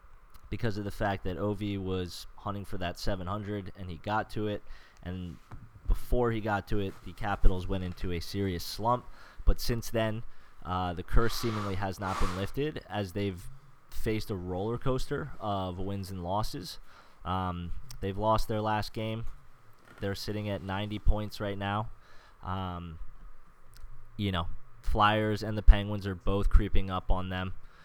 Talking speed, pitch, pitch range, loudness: 165 wpm, 100 Hz, 95-110 Hz, -33 LUFS